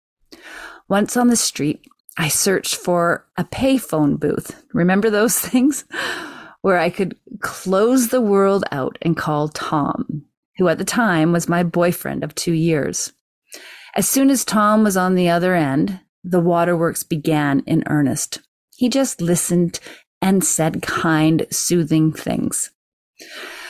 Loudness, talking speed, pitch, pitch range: -18 LUFS, 140 wpm, 175 Hz, 160-210 Hz